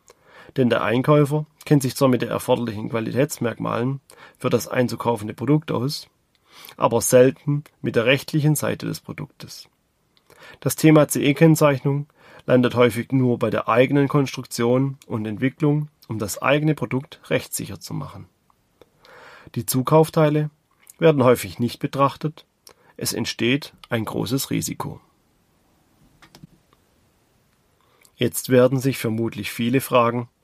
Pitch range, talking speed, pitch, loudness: 120-150 Hz, 115 wpm, 135 Hz, -21 LUFS